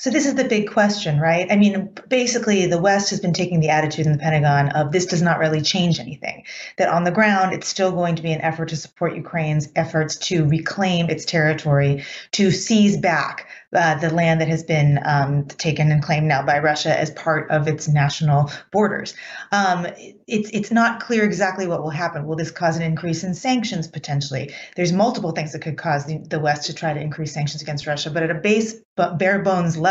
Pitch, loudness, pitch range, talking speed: 165 Hz, -20 LUFS, 155-190 Hz, 220 wpm